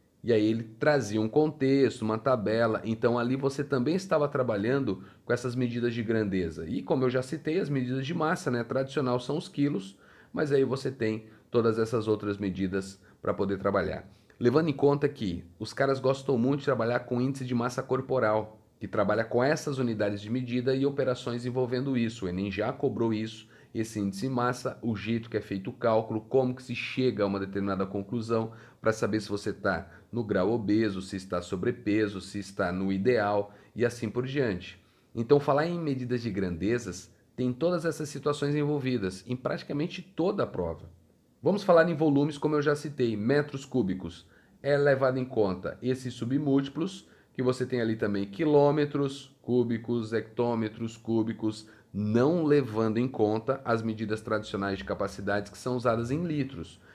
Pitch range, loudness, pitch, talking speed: 105-135 Hz, -29 LUFS, 120 Hz, 175 wpm